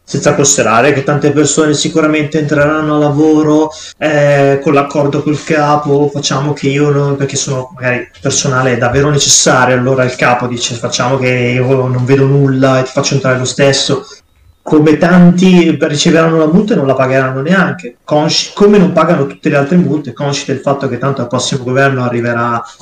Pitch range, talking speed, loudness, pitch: 130-150 Hz, 180 wpm, -10 LUFS, 140 Hz